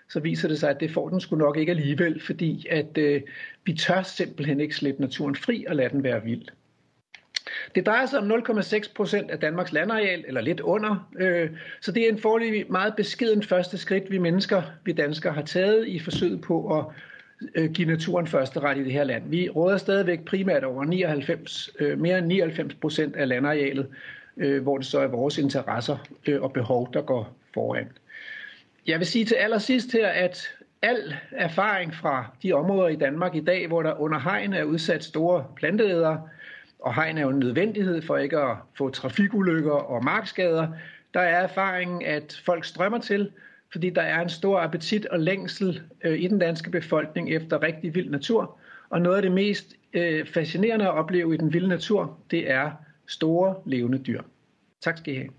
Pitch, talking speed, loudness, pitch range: 175 Hz, 190 wpm, -25 LUFS, 155-195 Hz